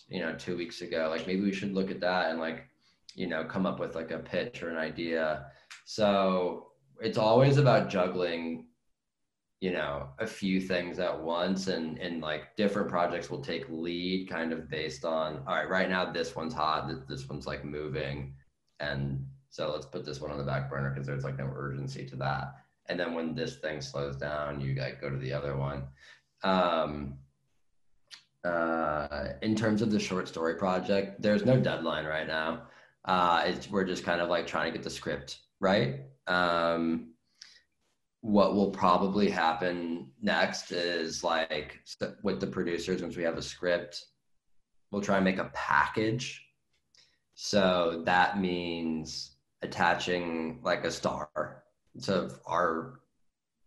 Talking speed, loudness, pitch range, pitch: 170 wpm, -31 LUFS, 75-90 Hz, 85 Hz